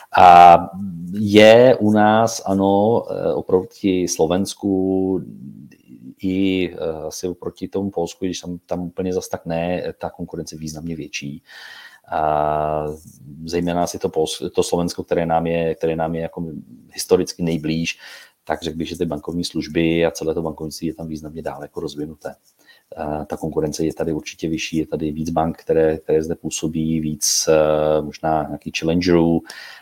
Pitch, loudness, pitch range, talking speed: 85 Hz, -19 LUFS, 80-90 Hz, 155 wpm